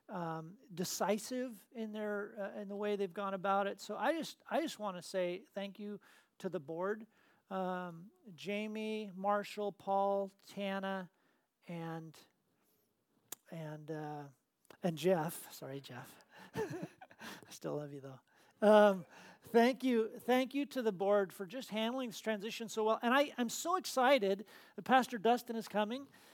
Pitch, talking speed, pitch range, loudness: 205 Hz, 155 wpm, 185-225 Hz, -37 LUFS